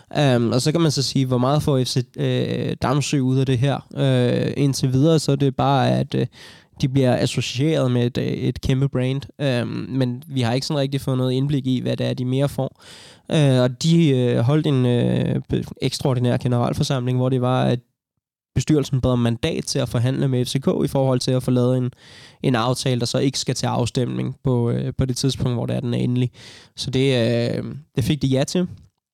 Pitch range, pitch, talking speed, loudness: 125-140 Hz, 130 Hz, 220 wpm, -21 LUFS